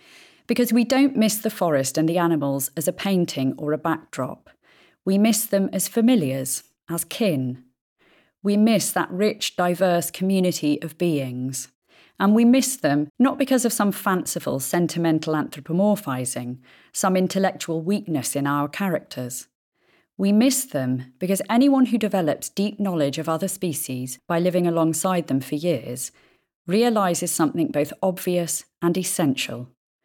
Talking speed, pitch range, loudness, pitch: 140 wpm, 145-205 Hz, -22 LUFS, 175 Hz